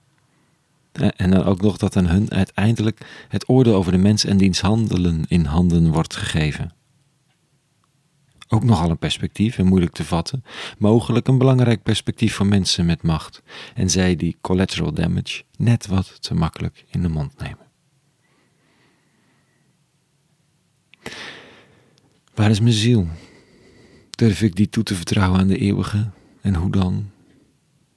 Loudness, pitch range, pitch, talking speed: -19 LUFS, 95-120 Hz, 105 Hz, 135 wpm